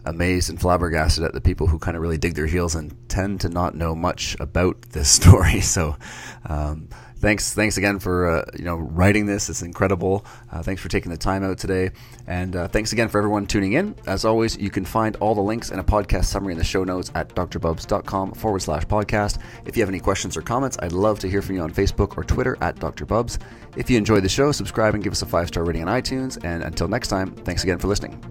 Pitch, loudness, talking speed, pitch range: 95 Hz, -22 LUFS, 240 wpm, 85-105 Hz